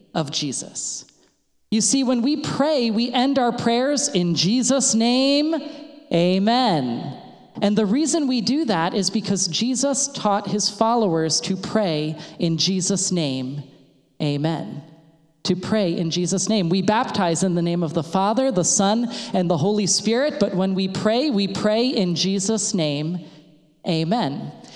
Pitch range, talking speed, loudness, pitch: 170-235 Hz, 150 wpm, -21 LUFS, 200 Hz